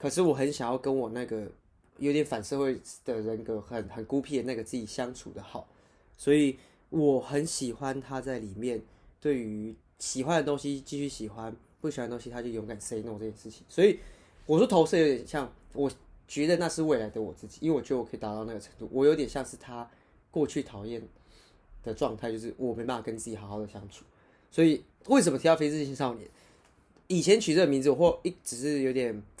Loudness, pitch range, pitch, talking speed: -30 LUFS, 110-145 Hz, 125 Hz, 320 characters per minute